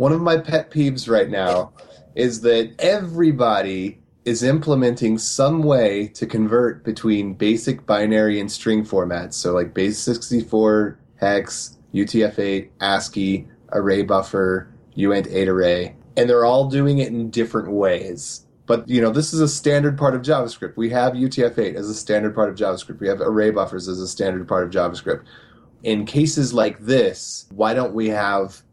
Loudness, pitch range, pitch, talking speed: -20 LUFS, 100-125 Hz, 110 Hz, 160 wpm